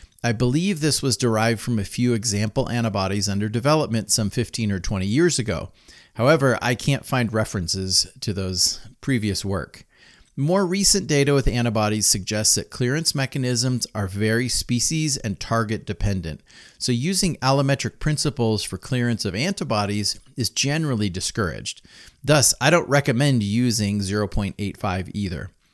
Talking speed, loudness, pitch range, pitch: 140 wpm, -22 LUFS, 100-135 Hz, 115 Hz